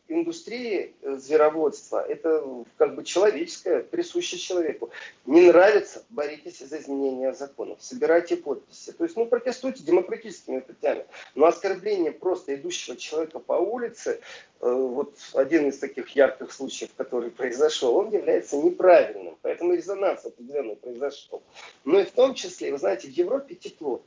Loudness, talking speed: -25 LUFS, 135 wpm